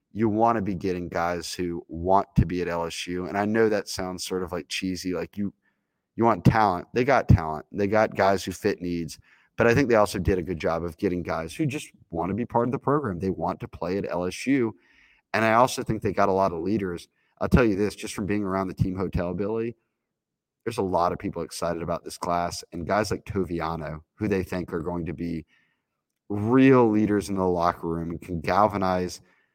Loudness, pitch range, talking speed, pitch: -25 LUFS, 85-105 Hz, 230 wpm, 95 Hz